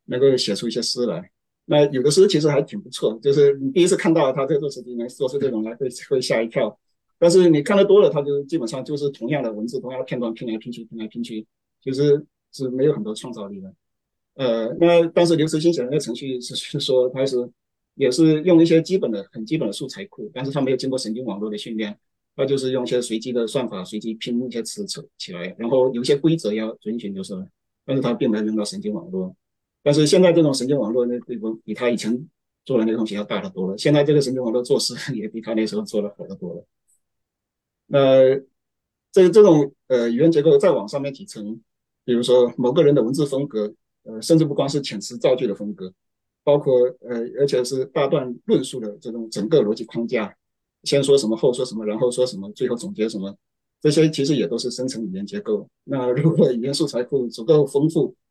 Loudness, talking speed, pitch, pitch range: -20 LUFS, 335 characters per minute, 130 Hz, 115-150 Hz